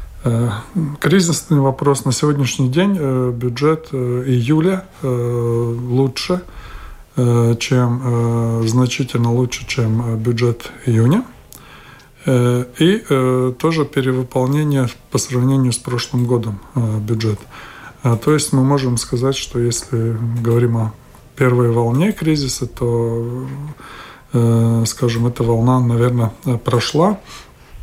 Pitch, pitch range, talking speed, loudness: 125 Hz, 120-135 Hz, 90 wpm, -17 LUFS